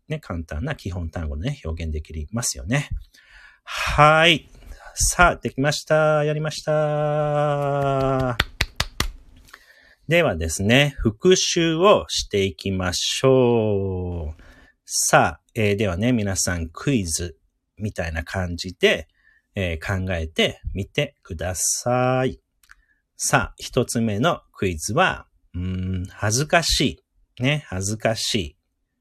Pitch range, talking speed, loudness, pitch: 90-140 Hz, 210 characters per minute, -21 LUFS, 105 Hz